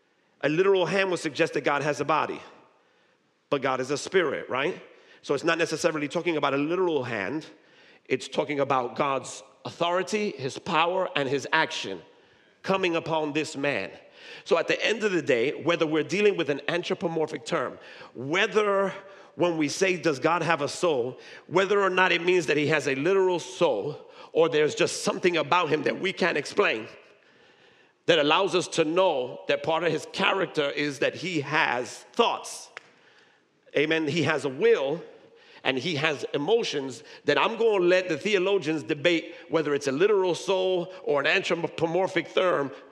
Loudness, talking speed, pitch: -26 LUFS, 170 wpm, 180 Hz